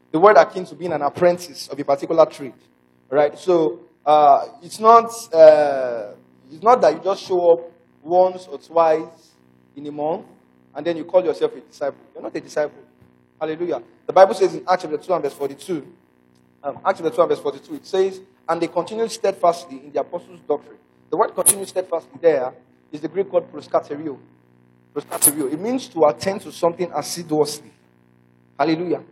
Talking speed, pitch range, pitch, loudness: 180 wpm, 135-185 Hz, 160 Hz, -19 LUFS